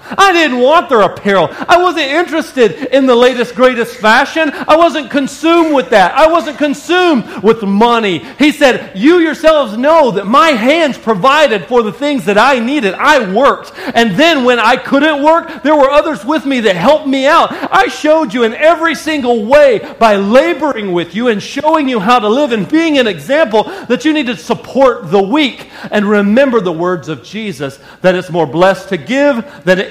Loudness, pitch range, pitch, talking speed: -10 LUFS, 220-305 Hz, 265 Hz, 195 wpm